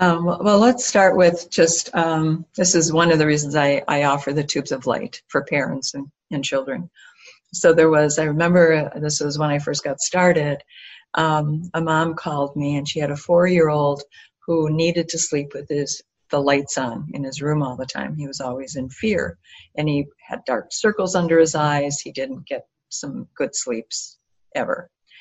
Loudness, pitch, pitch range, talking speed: -20 LUFS, 150 Hz, 145-165 Hz, 200 wpm